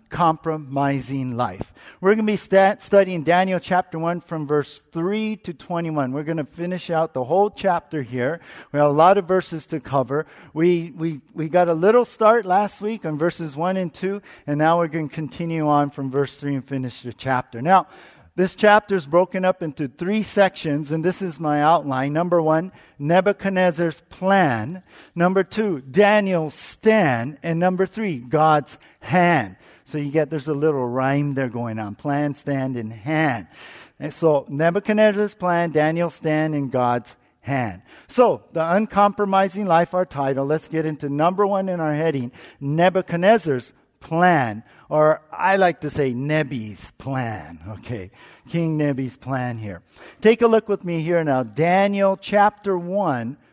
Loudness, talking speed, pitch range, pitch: -21 LUFS, 165 wpm, 140-185 Hz, 160 Hz